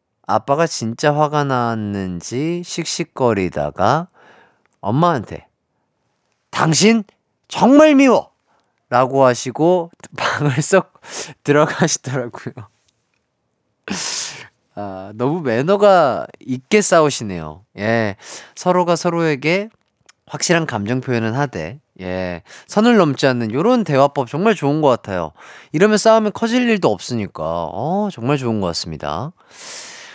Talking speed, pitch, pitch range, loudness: 235 characters per minute, 140 Hz, 110-180 Hz, -17 LUFS